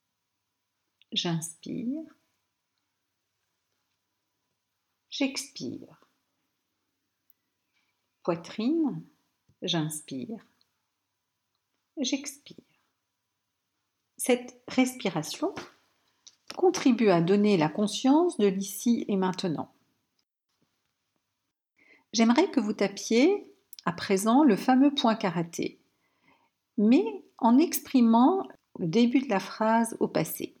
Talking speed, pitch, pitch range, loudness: 70 wpm, 230 Hz, 190-275 Hz, -26 LUFS